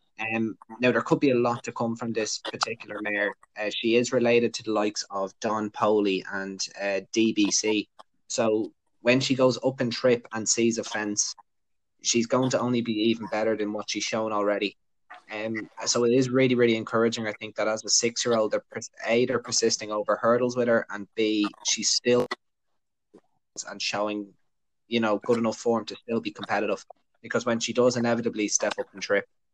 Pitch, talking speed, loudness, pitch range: 110 Hz, 195 wpm, -26 LUFS, 105-120 Hz